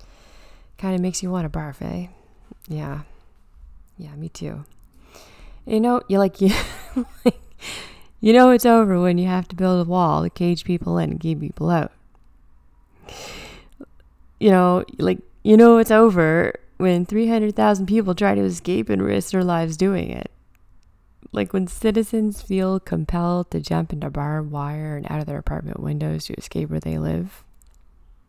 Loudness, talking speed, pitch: -20 LUFS, 165 wpm, 160 Hz